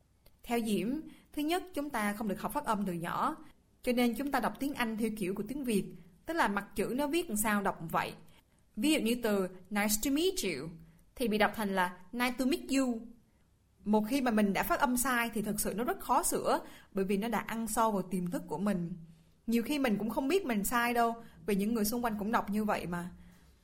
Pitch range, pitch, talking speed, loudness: 195-245 Hz, 220 Hz, 250 wpm, -33 LUFS